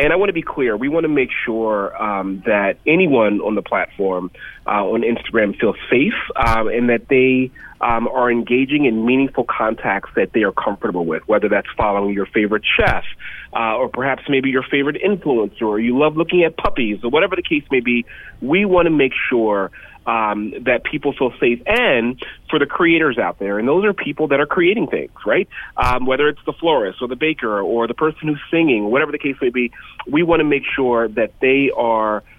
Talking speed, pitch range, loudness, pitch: 210 wpm, 110-150 Hz, -17 LUFS, 125 Hz